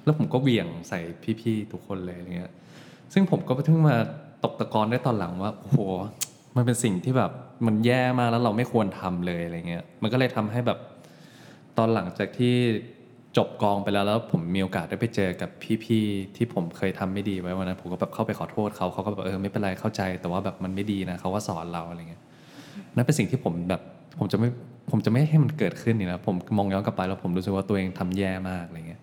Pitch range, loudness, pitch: 95-115 Hz, -27 LUFS, 100 Hz